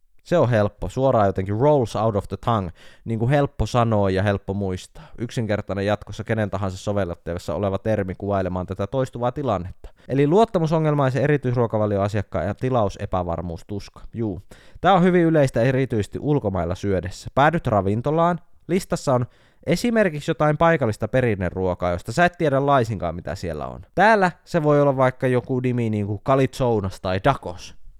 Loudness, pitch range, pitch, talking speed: -22 LUFS, 95-135 Hz, 110 Hz, 145 wpm